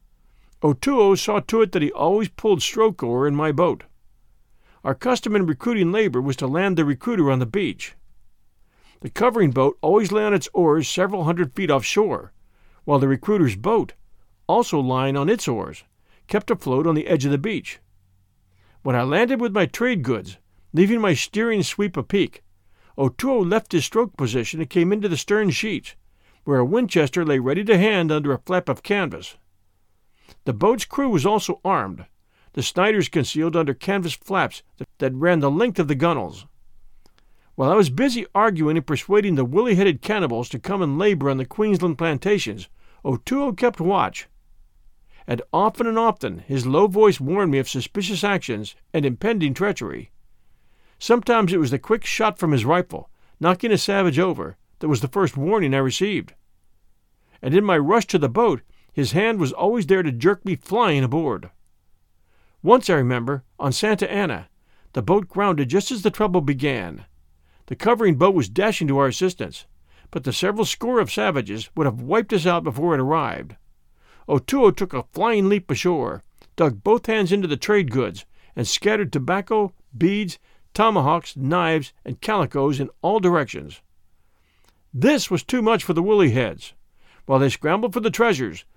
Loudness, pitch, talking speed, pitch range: -21 LUFS, 170 Hz, 175 wpm, 130-205 Hz